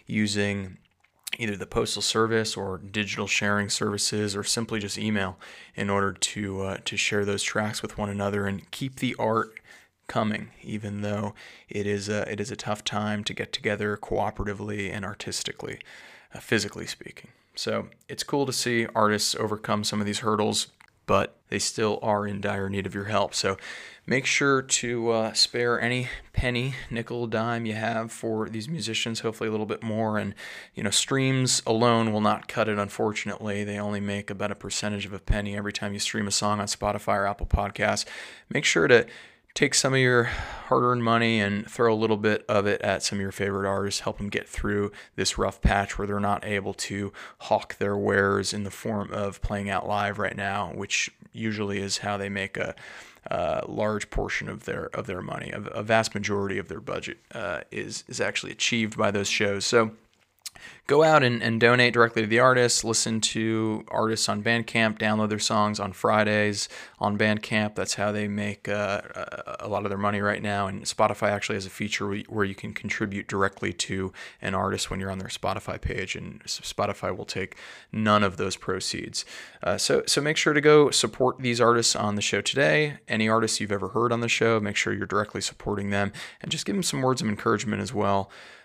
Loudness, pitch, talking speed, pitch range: -26 LUFS, 105 Hz, 200 wpm, 100-110 Hz